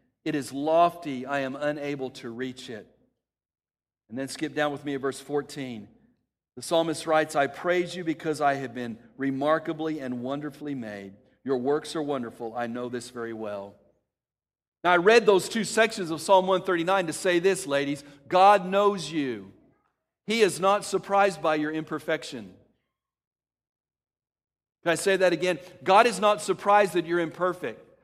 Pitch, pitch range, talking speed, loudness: 155 Hz, 135-180 Hz, 165 wpm, -26 LUFS